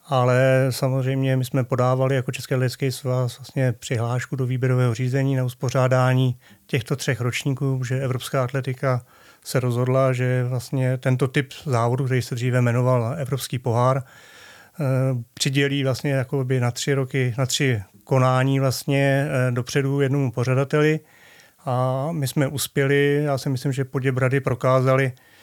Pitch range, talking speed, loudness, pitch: 125-140 Hz, 135 wpm, -22 LUFS, 130 Hz